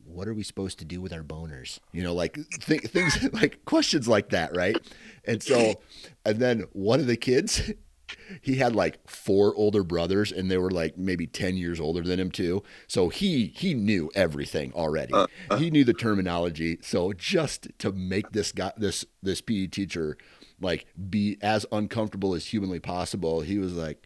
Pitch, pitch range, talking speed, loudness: 95 Hz, 85-110 Hz, 185 wpm, -27 LUFS